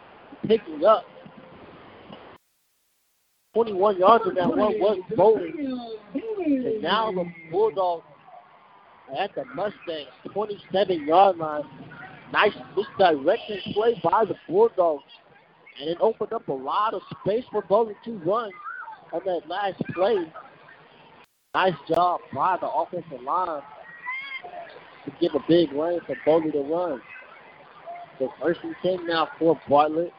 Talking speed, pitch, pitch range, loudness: 125 wpm, 200 Hz, 165-235 Hz, -24 LUFS